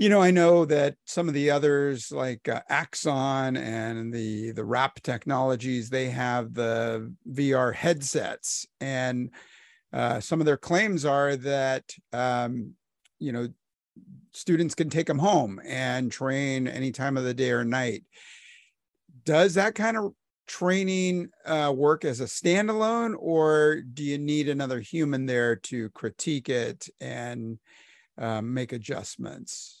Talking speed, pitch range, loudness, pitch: 145 wpm, 125-155 Hz, -26 LUFS, 135 Hz